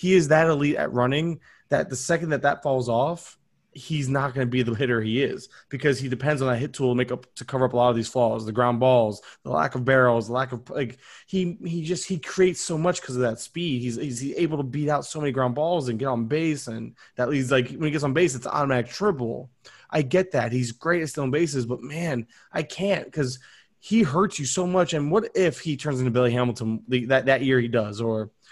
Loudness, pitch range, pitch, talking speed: -24 LUFS, 125-160 Hz, 135 Hz, 255 wpm